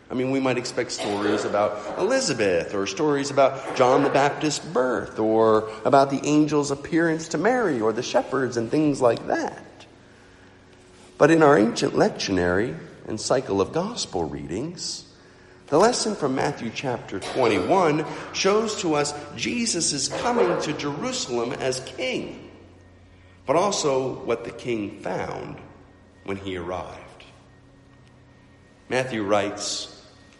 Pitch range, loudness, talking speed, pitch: 100-145 Hz, -23 LUFS, 130 wpm, 125 Hz